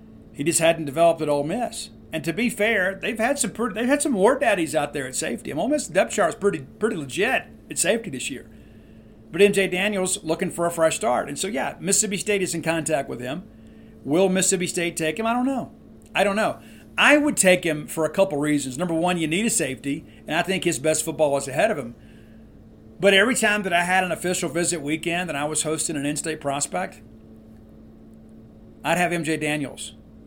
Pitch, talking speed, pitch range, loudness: 170 Hz, 220 wpm, 150-195 Hz, -22 LUFS